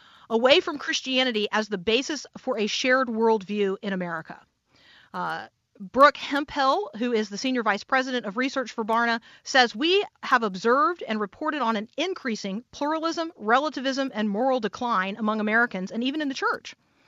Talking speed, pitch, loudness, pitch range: 160 wpm, 245 Hz, -25 LUFS, 215-275 Hz